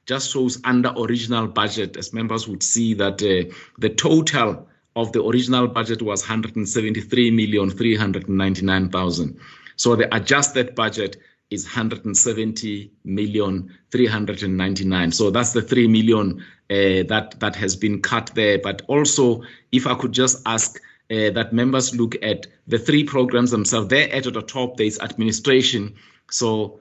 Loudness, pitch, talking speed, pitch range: -20 LUFS, 110 Hz, 135 wpm, 105-120 Hz